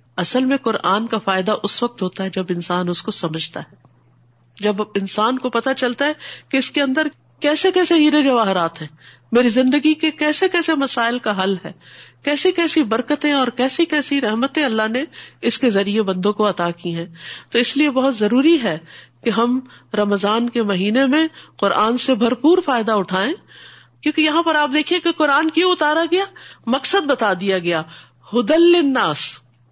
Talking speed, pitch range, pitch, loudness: 180 wpm, 195-295 Hz, 240 Hz, -18 LUFS